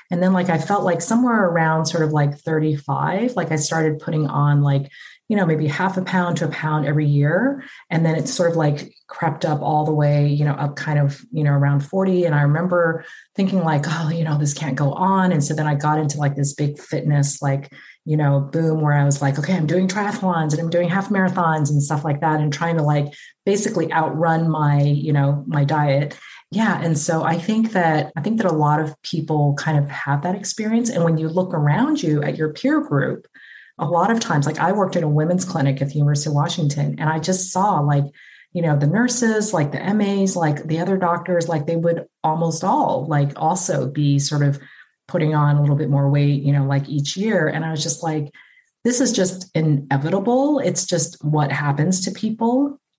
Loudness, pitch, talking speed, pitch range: -20 LUFS, 160 Hz, 225 wpm, 145-180 Hz